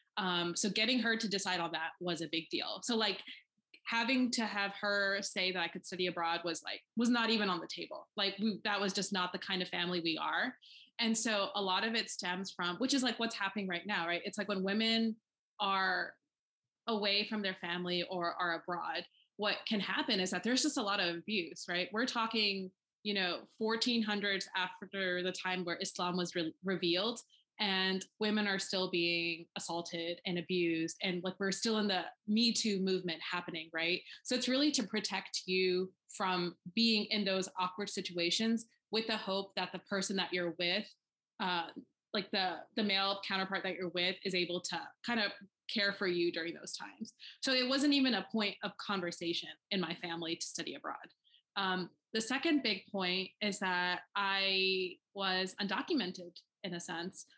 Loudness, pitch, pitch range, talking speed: -35 LUFS, 195 Hz, 180-215 Hz, 190 wpm